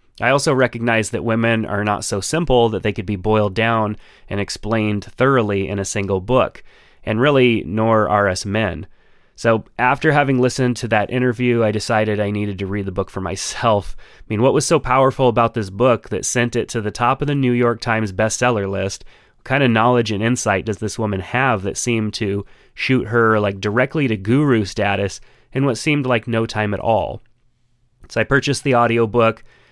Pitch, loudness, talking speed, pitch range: 115 Hz, -18 LUFS, 200 wpm, 105-125 Hz